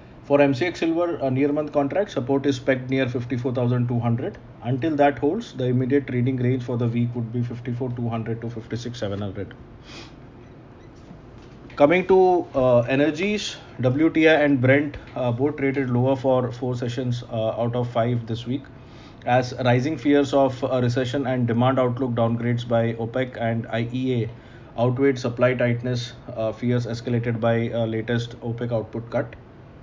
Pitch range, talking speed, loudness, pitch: 120-135 Hz, 145 wpm, -23 LUFS, 125 Hz